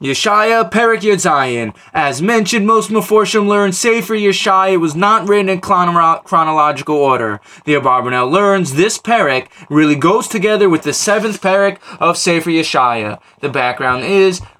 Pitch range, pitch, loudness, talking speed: 145-210 Hz, 185 Hz, -13 LUFS, 145 wpm